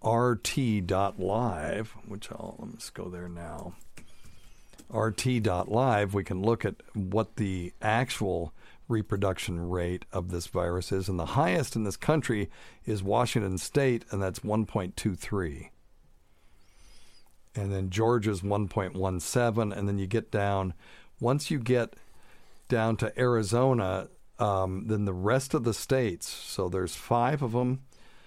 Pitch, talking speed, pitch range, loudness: 105 Hz, 130 wpm, 95-115 Hz, -29 LUFS